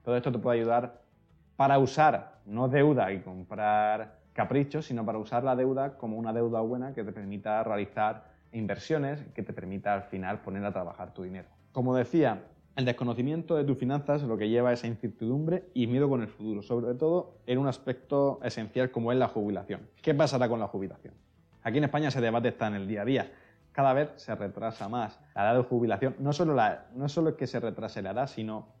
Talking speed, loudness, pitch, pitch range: 215 wpm, -30 LUFS, 120 Hz, 105-135 Hz